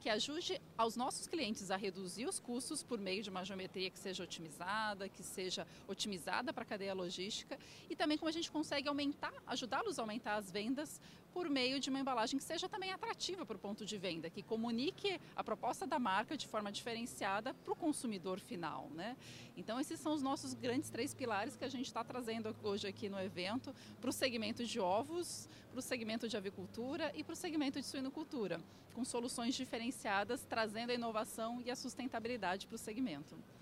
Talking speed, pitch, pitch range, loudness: 195 wpm, 240 Hz, 205-275 Hz, -42 LUFS